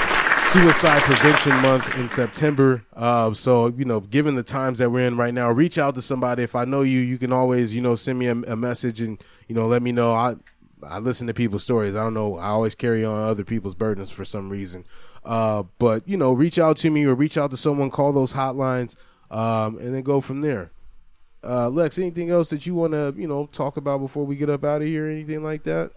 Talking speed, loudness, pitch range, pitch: 245 wpm, -21 LUFS, 115-145 Hz, 125 Hz